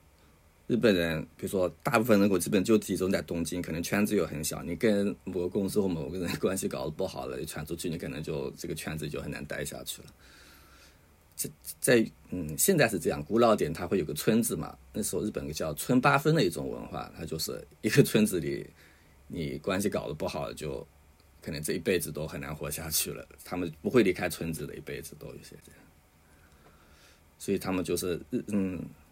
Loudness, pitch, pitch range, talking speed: -30 LUFS, 80 Hz, 75-90 Hz, 300 characters per minute